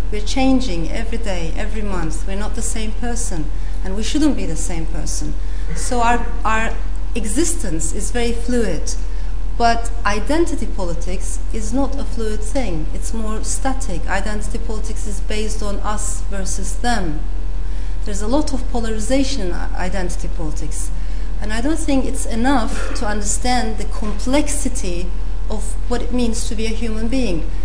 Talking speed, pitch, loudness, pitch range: 155 wpm, 230 Hz, -22 LUFS, 210-255 Hz